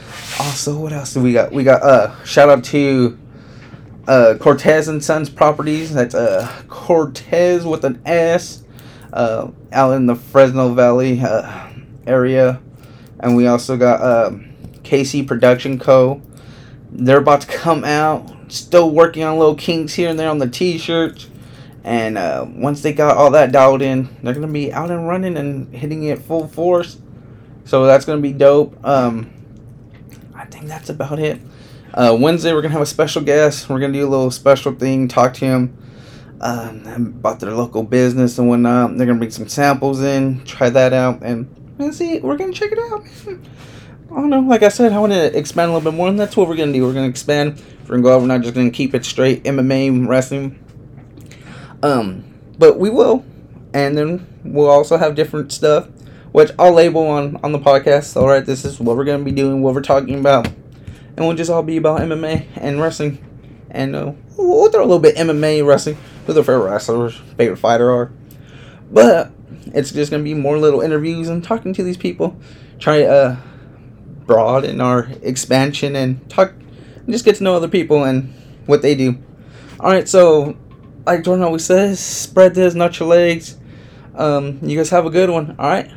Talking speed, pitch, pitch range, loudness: 195 wpm, 140 Hz, 130-155 Hz, -15 LUFS